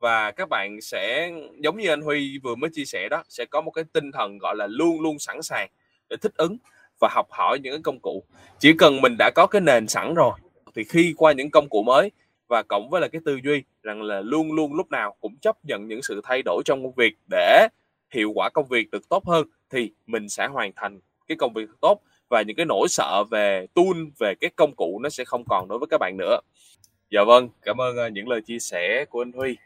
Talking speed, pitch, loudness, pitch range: 245 wpm, 145 Hz, -22 LUFS, 115-160 Hz